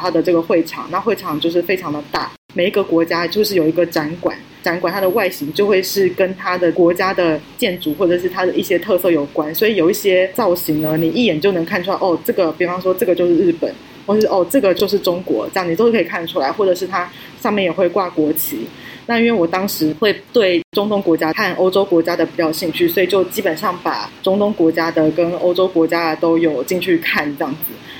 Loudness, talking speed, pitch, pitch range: -16 LUFS, 345 characters per minute, 180 Hz, 165-190 Hz